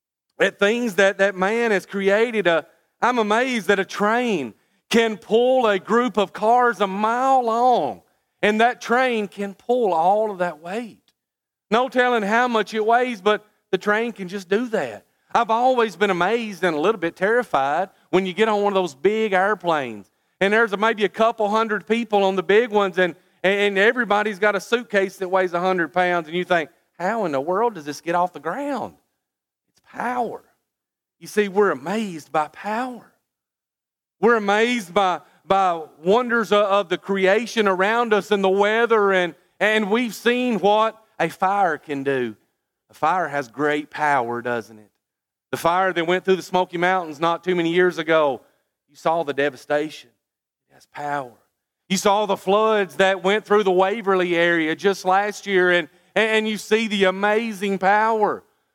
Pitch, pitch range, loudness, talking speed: 200 Hz, 180-220 Hz, -20 LUFS, 175 wpm